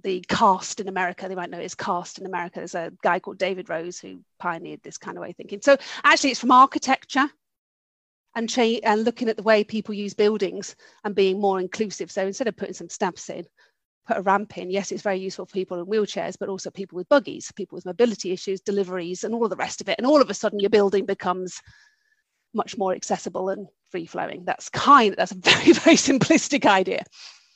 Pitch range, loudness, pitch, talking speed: 185-230 Hz, -22 LUFS, 200 Hz, 220 wpm